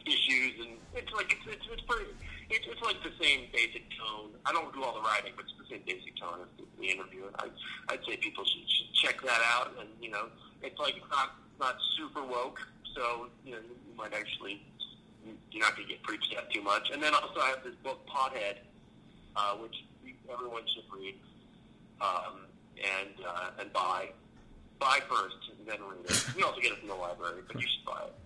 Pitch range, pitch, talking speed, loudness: 100-125 Hz, 115 Hz, 215 wpm, -33 LUFS